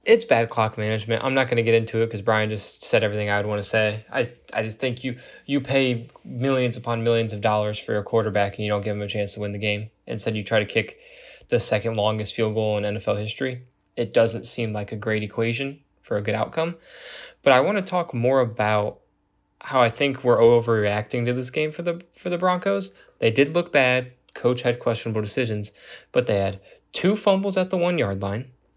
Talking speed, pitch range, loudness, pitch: 225 wpm, 105-135 Hz, -23 LUFS, 115 Hz